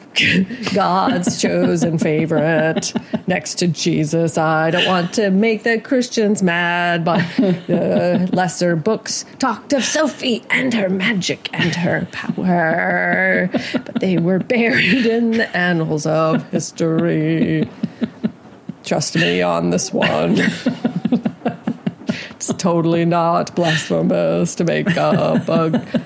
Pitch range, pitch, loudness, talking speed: 165-220 Hz, 180 Hz, -17 LUFS, 115 wpm